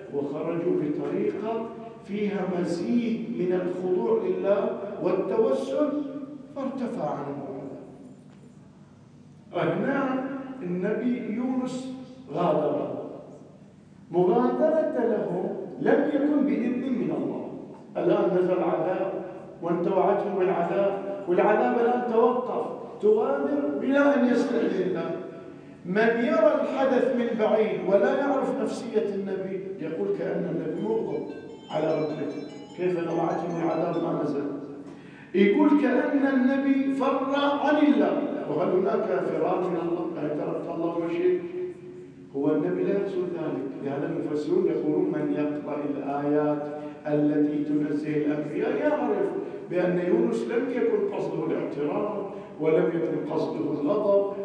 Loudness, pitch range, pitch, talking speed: -26 LUFS, 170-255 Hz, 195 Hz, 105 wpm